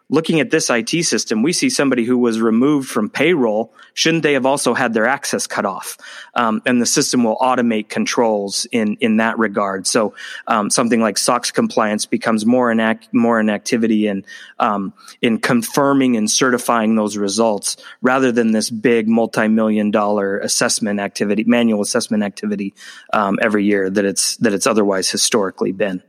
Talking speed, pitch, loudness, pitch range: 175 wpm, 115 Hz, -16 LUFS, 105-125 Hz